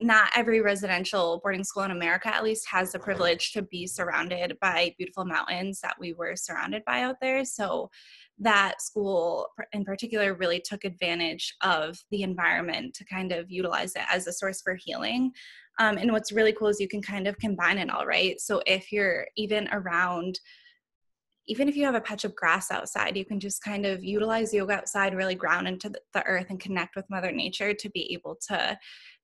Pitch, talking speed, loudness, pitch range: 195 Hz, 195 wpm, -28 LUFS, 180-215 Hz